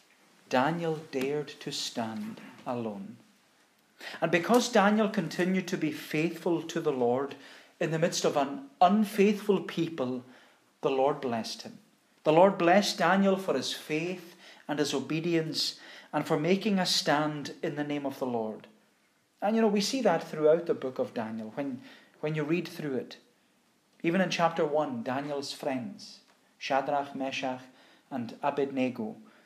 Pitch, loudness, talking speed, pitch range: 160 Hz, -29 LUFS, 150 wpm, 140-185 Hz